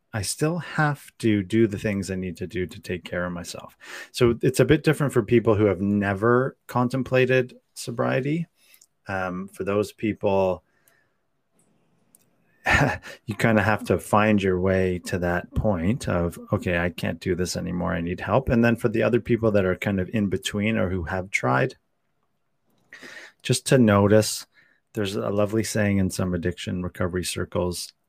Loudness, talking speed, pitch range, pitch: -24 LUFS, 175 wpm, 90-120 Hz, 105 Hz